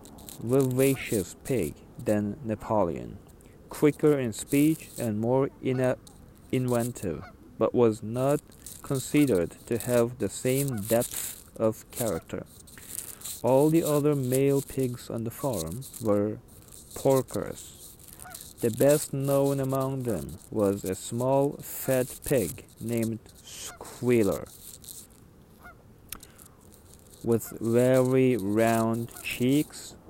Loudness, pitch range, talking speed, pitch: -27 LUFS, 105-135 Hz, 95 wpm, 120 Hz